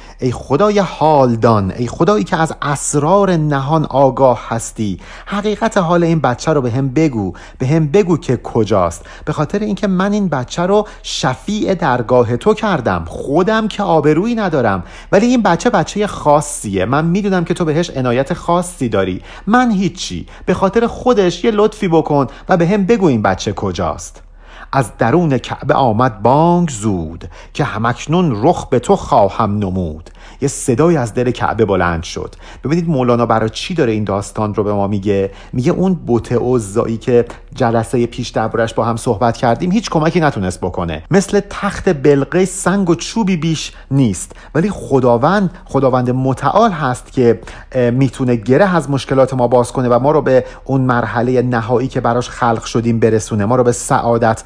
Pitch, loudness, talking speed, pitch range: 130 Hz, -15 LUFS, 165 wpm, 115-175 Hz